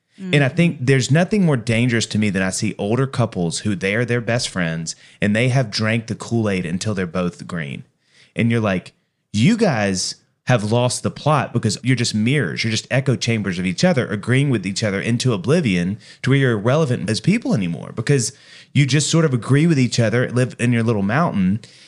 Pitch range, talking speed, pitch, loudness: 105-135 Hz, 215 wpm, 120 Hz, -19 LUFS